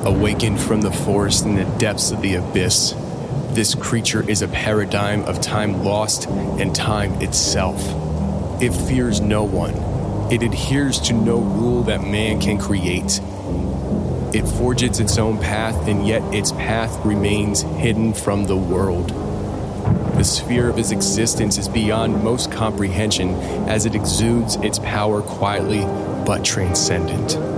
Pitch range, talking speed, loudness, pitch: 95-110 Hz, 140 wpm, -19 LUFS, 105 Hz